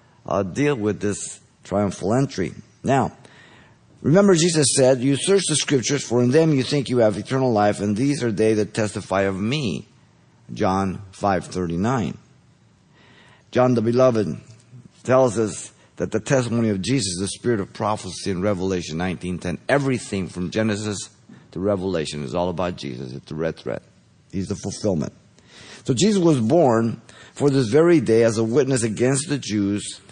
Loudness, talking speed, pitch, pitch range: -21 LUFS, 160 wpm, 110 Hz, 95-130 Hz